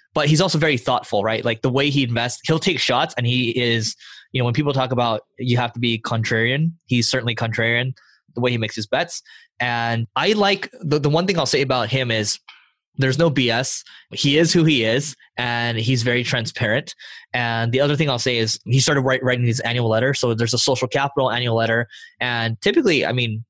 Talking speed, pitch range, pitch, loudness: 220 wpm, 115-140 Hz, 125 Hz, -20 LUFS